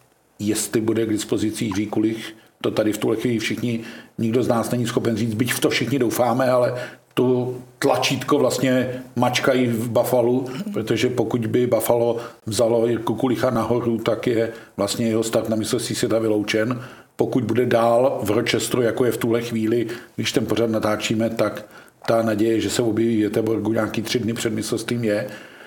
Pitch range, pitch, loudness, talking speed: 110-125 Hz, 115 Hz, -21 LUFS, 170 wpm